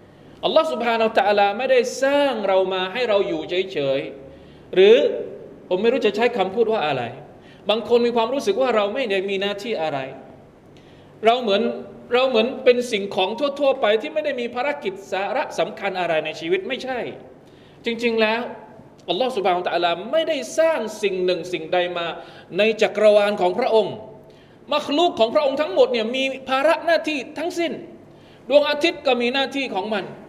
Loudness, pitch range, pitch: -21 LUFS, 190-275 Hz, 225 Hz